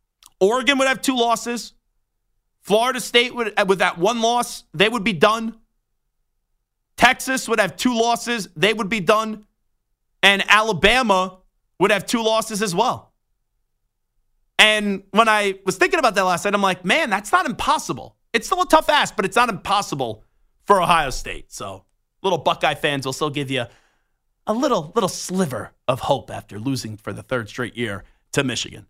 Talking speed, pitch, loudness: 170 wpm, 200 Hz, -19 LUFS